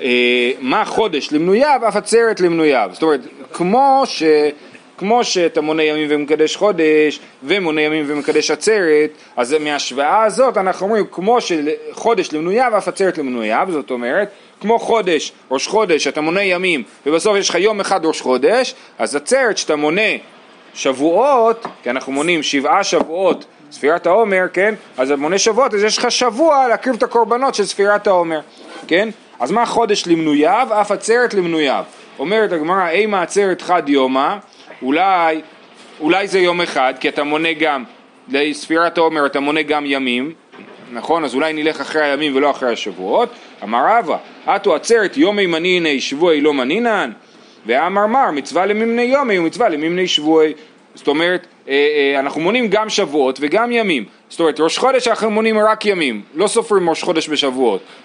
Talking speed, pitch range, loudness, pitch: 155 wpm, 150-215 Hz, -15 LUFS, 175 Hz